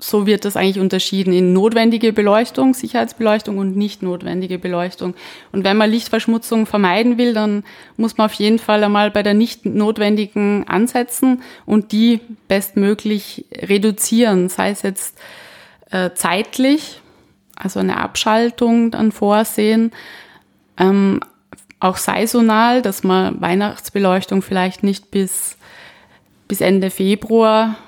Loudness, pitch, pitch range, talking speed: -16 LUFS, 210 Hz, 195-225 Hz, 125 wpm